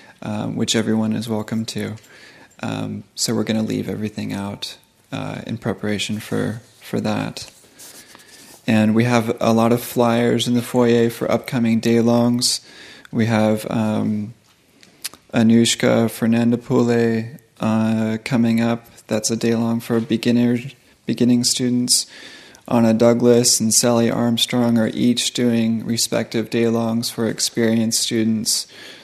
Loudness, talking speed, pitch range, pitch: -19 LUFS, 130 wpm, 110-120 Hz, 115 Hz